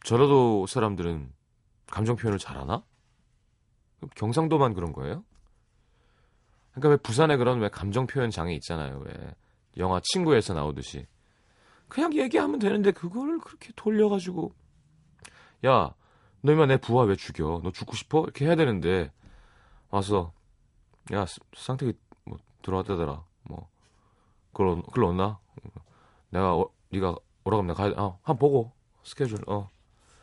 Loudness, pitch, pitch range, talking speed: -27 LUFS, 110 Hz, 95-140 Hz, 270 characters per minute